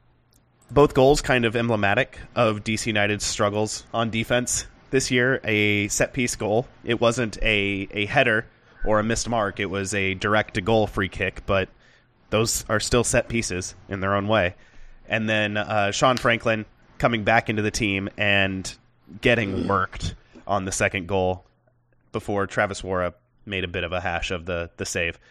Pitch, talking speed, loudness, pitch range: 105 Hz, 170 wpm, -23 LUFS, 100-115 Hz